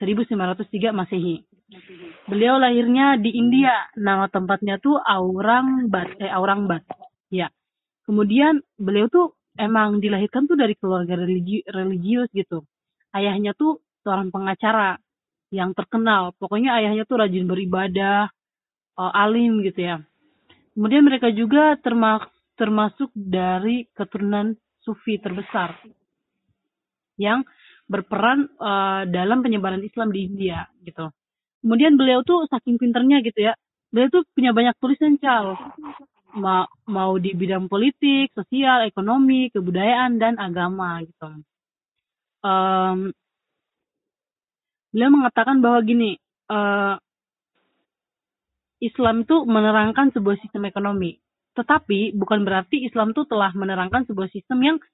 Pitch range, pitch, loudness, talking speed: 190-245 Hz, 210 Hz, -20 LUFS, 110 wpm